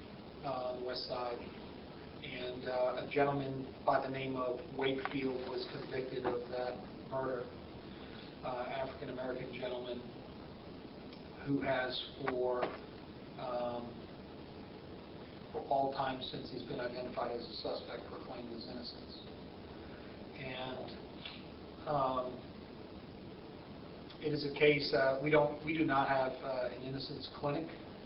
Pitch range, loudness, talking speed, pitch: 125-140 Hz, -38 LUFS, 120 wpm, 130 Hz